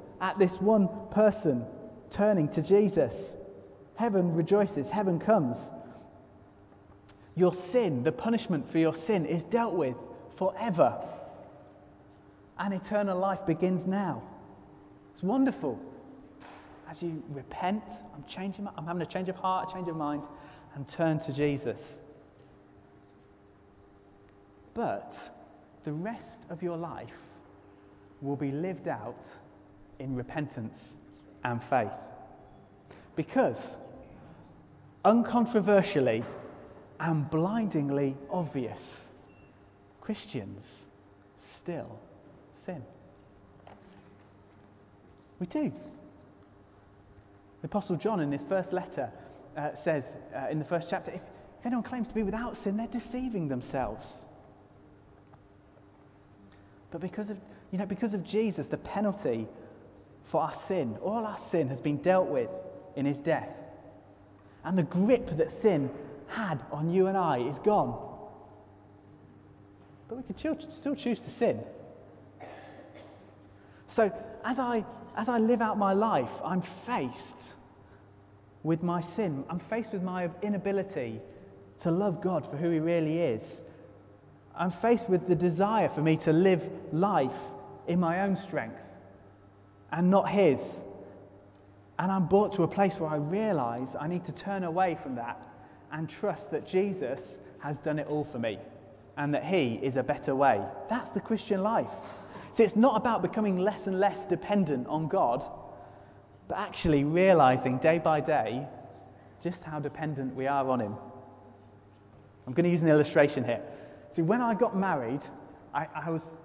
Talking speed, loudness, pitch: 135 wpm, -30 LUFS, 155 Hz